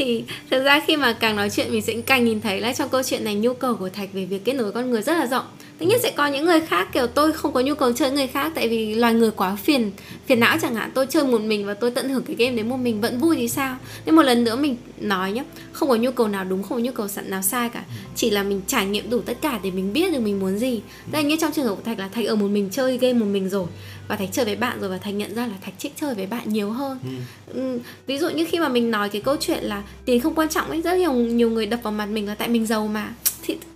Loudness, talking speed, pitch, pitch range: -22 LUFS, 310 wpm, 240 Hz, 210-275 Hz